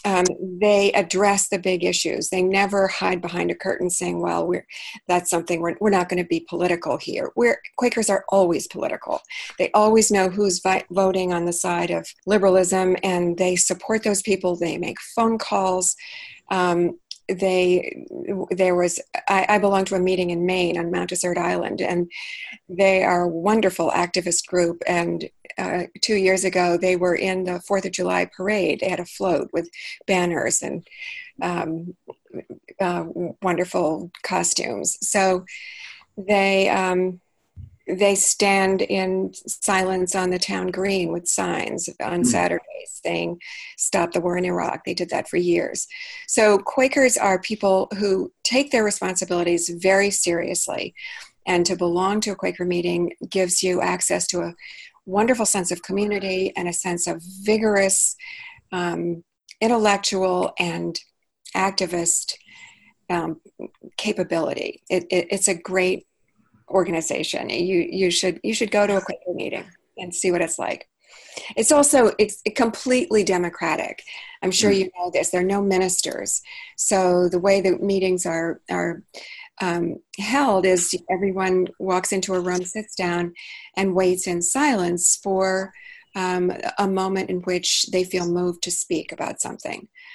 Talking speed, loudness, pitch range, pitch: 150 wpm, -21 LUFS, 180-200 Hz, 185 Hz